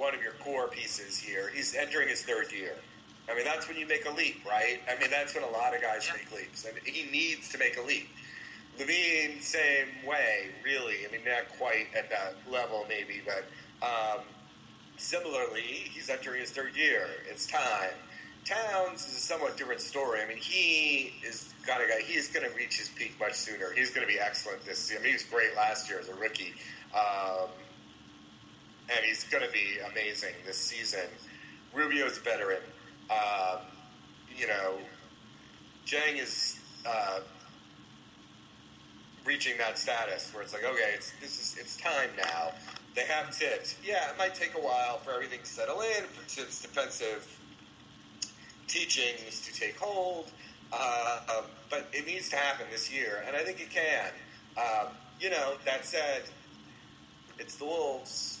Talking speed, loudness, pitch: 180 wpm, -32 LUFS, 155 Hz